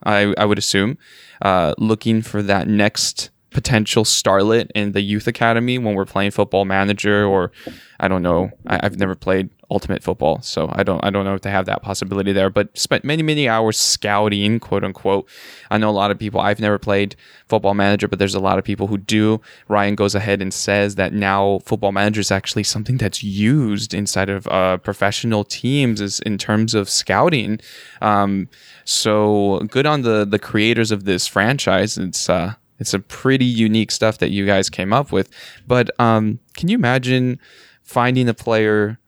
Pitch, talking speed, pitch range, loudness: 105 Hz, 190 wpm, 100-110 Hz, -18 LUFS